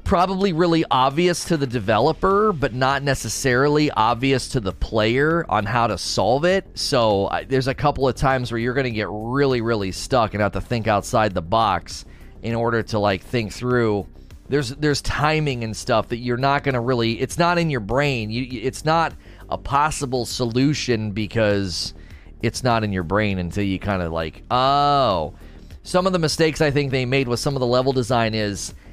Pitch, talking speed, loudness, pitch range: 125 Hz, 195 wpm, -21 LUFS, 105-140 Hz